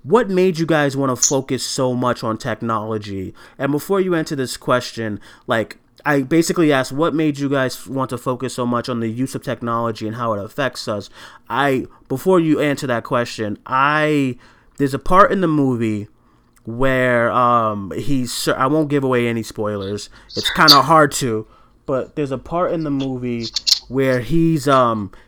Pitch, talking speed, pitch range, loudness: 130 Hz, 185 wpm, 115-145 Hz, -18 LUFS